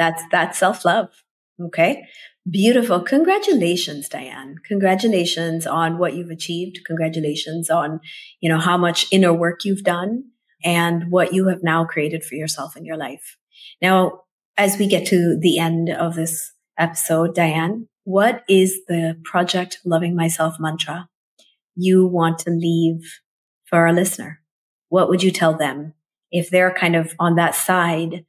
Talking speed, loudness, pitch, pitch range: 150 wpm, -19 LUFS, 170 Hz, 165-185 Hz